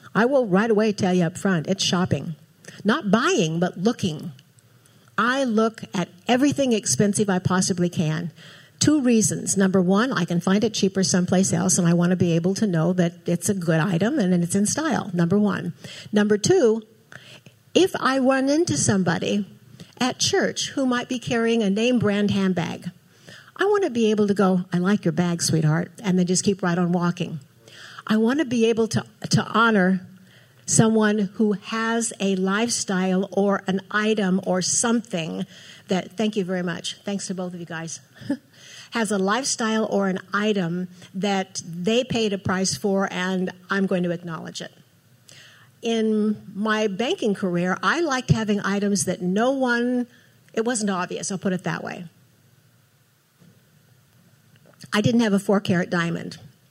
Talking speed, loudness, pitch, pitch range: 170 wpm, -22 LUFS, 190 Hz, 175-215 Hz